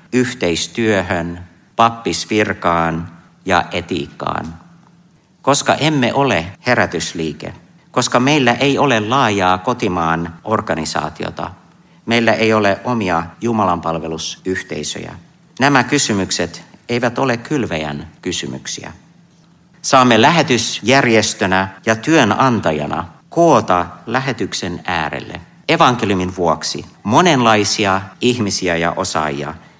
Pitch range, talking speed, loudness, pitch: 85-130 Hz, 80 wpm, -16 LUFS, 110 Hz